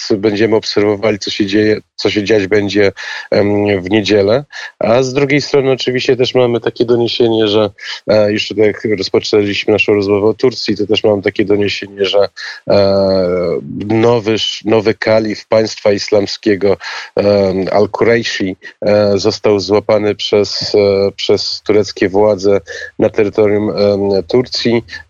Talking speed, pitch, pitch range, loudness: 135 wpm, 105 Hz, 100-110 Hz, -13 LUFS